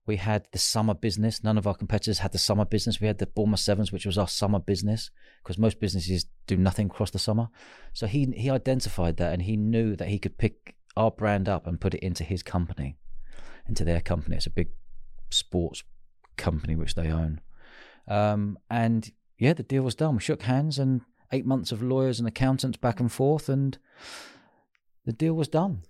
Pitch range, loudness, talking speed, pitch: 95-115 Hz, -27 LUFS, 205 wpm, 105 Hz